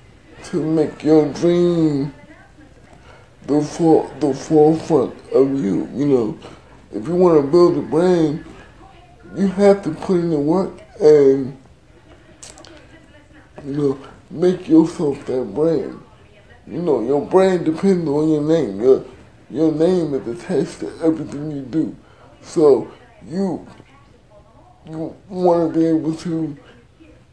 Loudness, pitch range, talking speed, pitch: -17 LUFS, 145-175 Hz, 125 wpm, 160 Hz